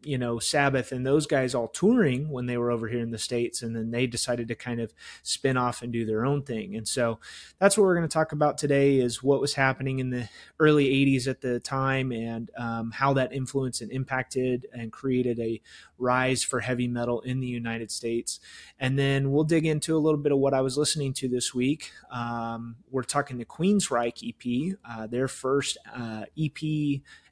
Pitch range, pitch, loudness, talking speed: 120-140 Hz, 130 Hz, -27 LUFS, 215 wpm